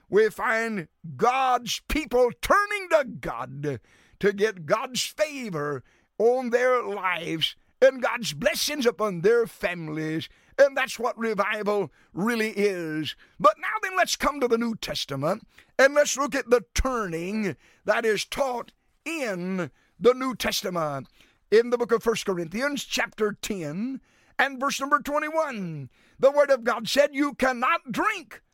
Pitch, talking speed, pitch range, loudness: 235 Hz, 145 wpm, 195-275 Hz, -25 LUFS